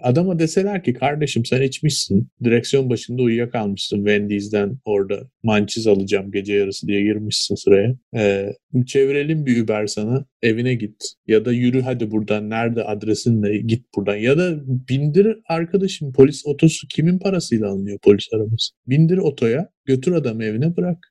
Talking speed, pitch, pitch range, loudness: 145 wpm, 120 Hz, 105-145 Hz, -19 LUFS